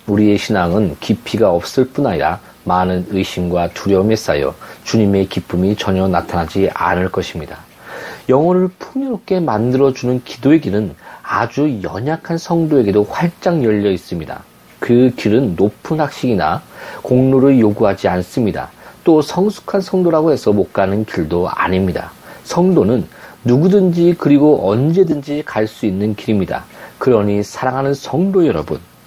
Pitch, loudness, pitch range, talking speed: 110 Hz, -15 LUFS, 95-150 Hz, 315 characters per minute